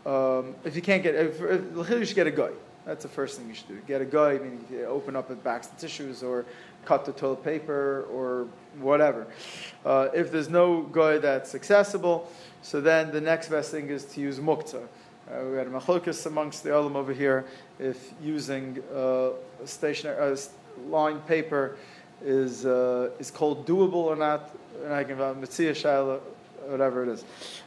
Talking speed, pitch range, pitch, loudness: 185 wpm, 135-160 Hz, 145 Hz, -27 LUFS